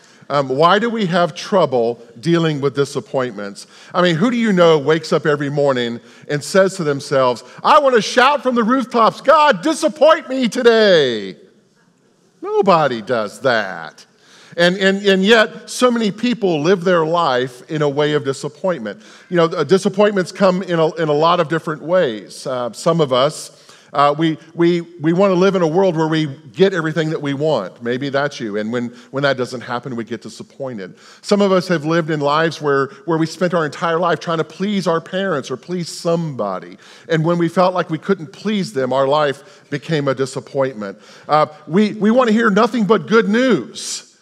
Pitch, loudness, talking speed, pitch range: 165 Hz, -16 LUFS, 195 wpm, 140-195 Hz